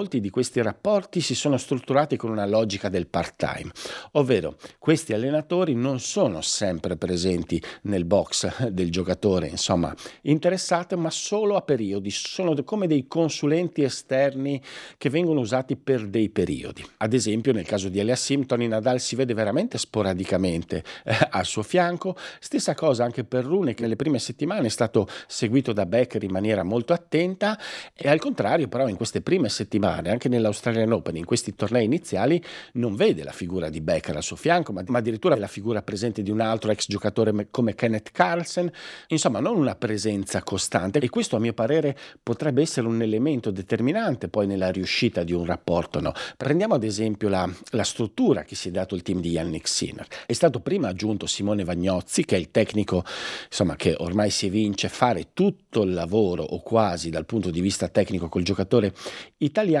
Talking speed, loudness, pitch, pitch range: 180 wpm, -24 LUFS, 115 Hz, 100-140 Hz